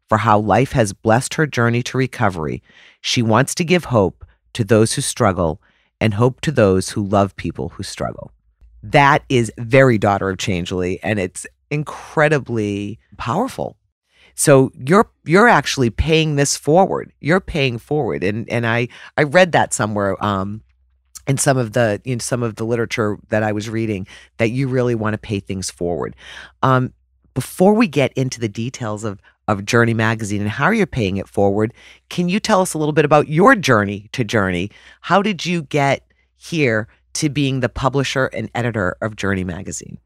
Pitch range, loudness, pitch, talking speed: 100-135 Hz, -18 LUFS, 115 Hz, 180 wpm